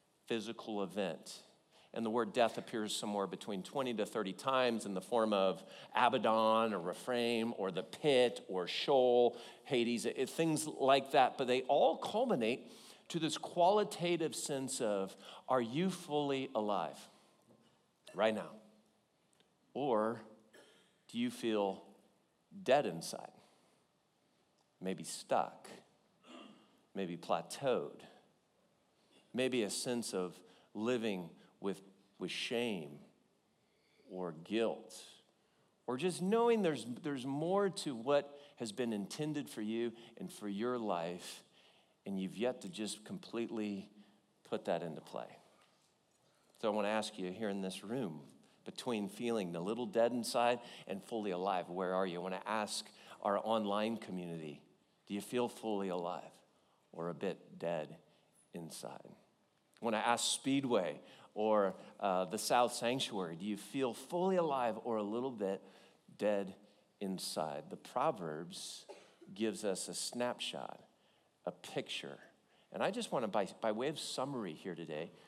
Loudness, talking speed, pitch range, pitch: -37 LUFS, 135 wpm, 100-130 Hz, 110 Hz